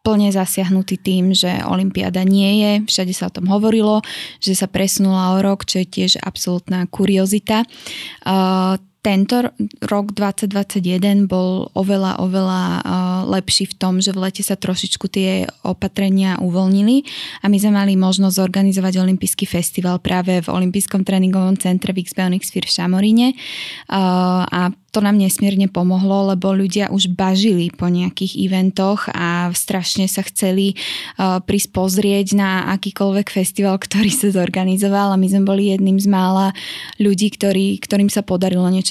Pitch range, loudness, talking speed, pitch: 185-200 Hz, -17 LUFS, 145 wpm, 190 Hz